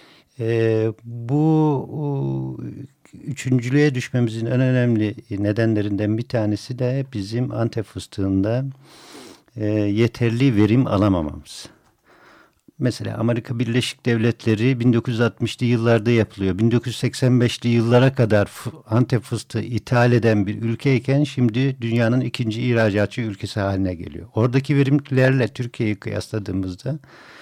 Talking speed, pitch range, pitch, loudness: 95 wpm, 105-125 Hz, 115 Hz, -20 LUFS